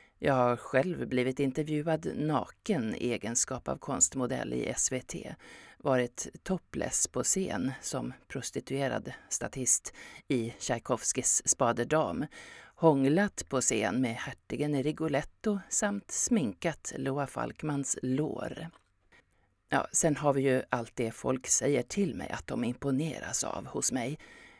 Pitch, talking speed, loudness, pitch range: 140 Hz, 120 wpm, -31 LUFS, 125-160 Hz